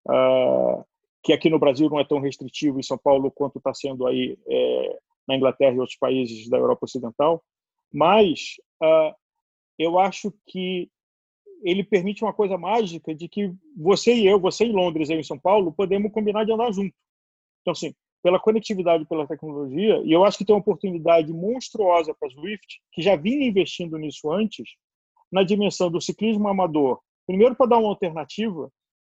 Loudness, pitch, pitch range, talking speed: -22 LUFS, 185 Hz, 155-220 Hz, 175 wpm